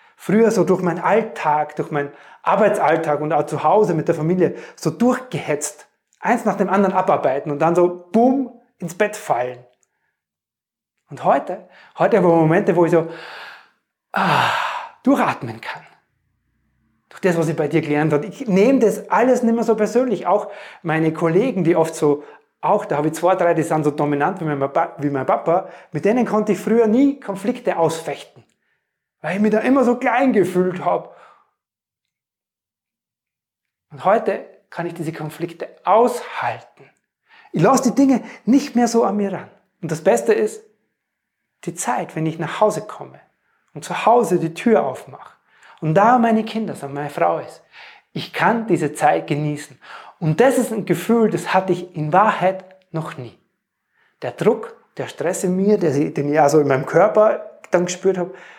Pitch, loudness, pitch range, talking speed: 180 Hz, -18 LUFS, 155-220 Hz, 175 wpm